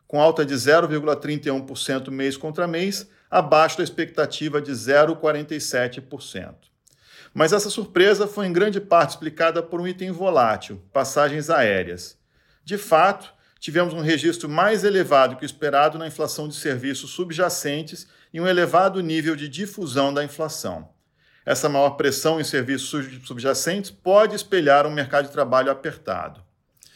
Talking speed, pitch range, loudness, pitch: 140 wpm, 140-175 Hz, -21 LUFS, 155 Hz